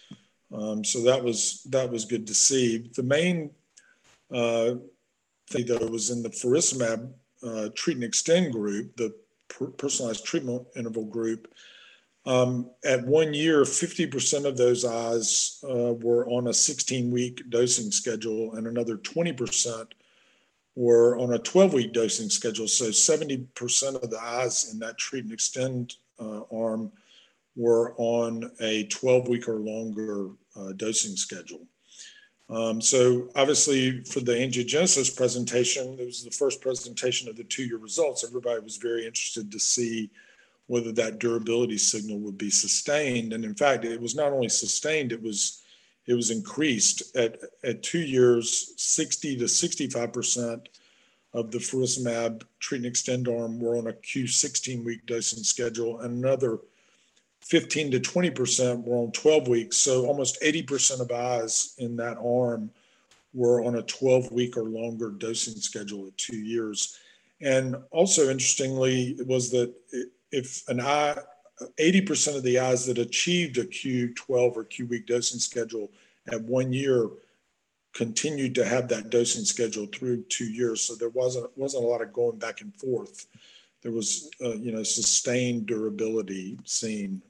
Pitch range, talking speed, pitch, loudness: 115-135 Hz, 155 wpm, 120 Hz, -26 LUFS